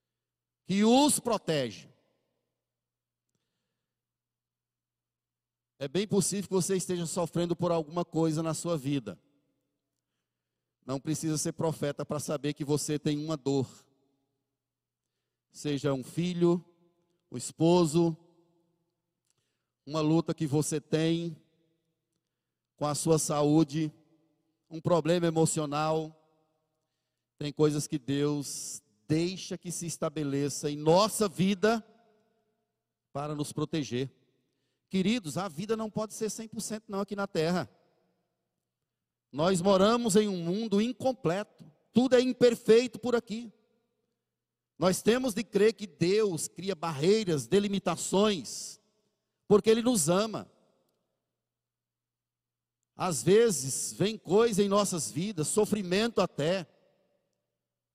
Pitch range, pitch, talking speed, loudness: 150-200 Hz, 165 Hz, 105 wpm, -29 LUFS